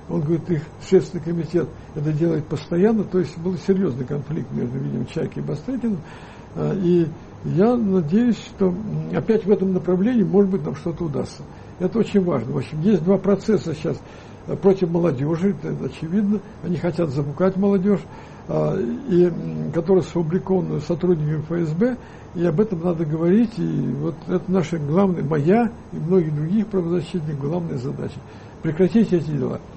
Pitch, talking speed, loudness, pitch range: 175 Hz, 145 wpm, -21 LUFS, 160-195 Hz